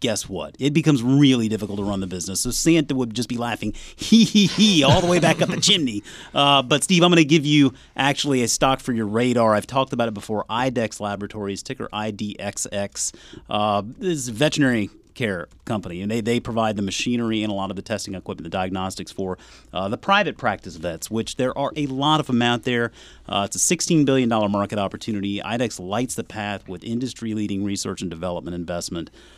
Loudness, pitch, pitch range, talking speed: -21 LUFS, 115 Hz, 100-135 Hz, 210 wpm